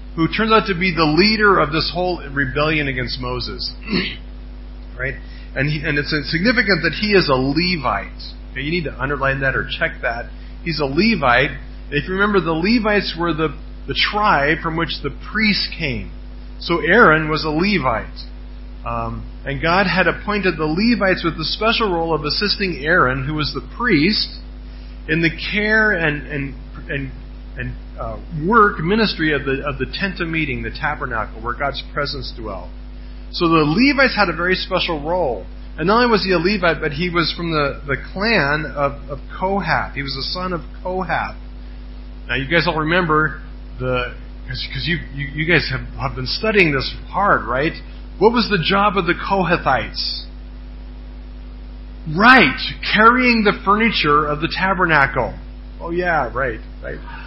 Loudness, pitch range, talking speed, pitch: -18 LUFS, 130-185 Hz, 170 wpm, 155 Hz